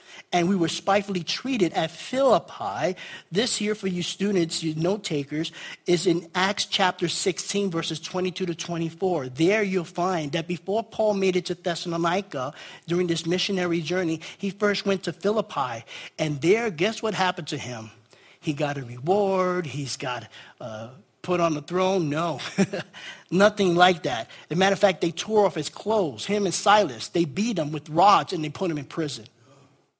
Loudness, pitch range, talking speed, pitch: -25 LUFS, 160-195 Hz, 180 wpm, 180 Hz